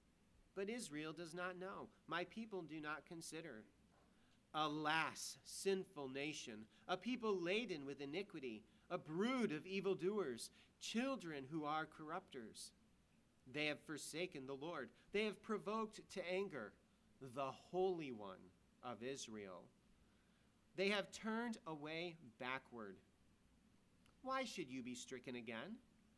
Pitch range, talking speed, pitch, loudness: 140-195 Hz, 120 wpm, 165 Hz, -47 LUFS